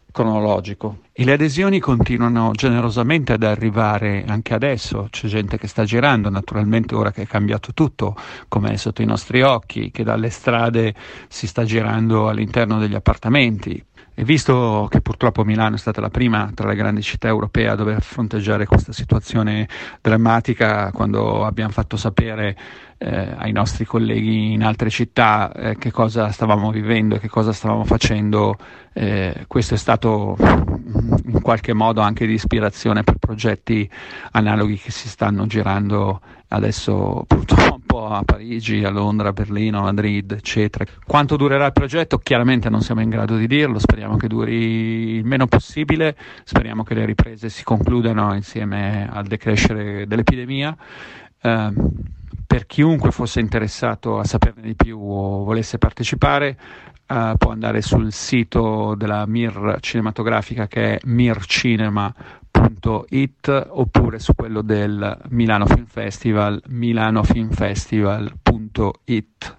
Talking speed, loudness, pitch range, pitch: 145 wpm, -19 LUFS, 105-115 Hz, 110 Hz